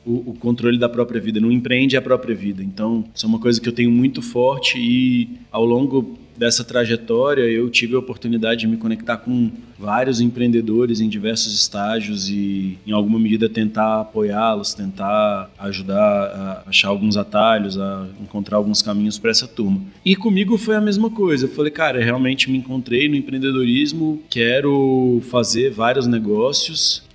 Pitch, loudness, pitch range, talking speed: 115 Hz, -18 LUFS, 105-130 Hz, 170 wpm